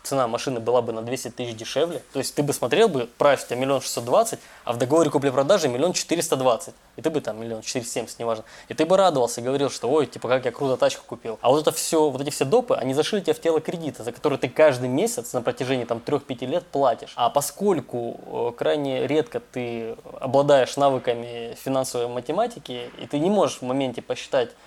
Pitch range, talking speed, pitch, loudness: 120-150 Hz, 220 wpm, 130 Hz, -23 LUFS